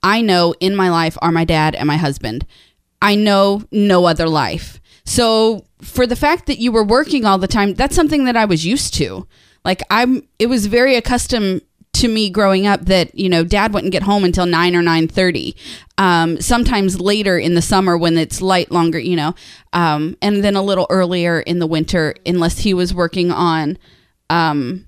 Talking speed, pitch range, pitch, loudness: 200 wpm, 170-210 Hz, 185 Hz, -15 LUFS